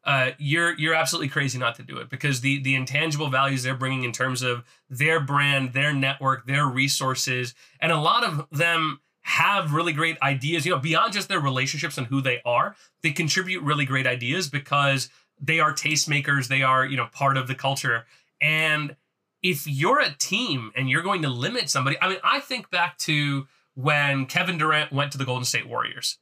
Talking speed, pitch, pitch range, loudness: 200 wpm, 140 Hz, 135-160 Hz, -23 LUFS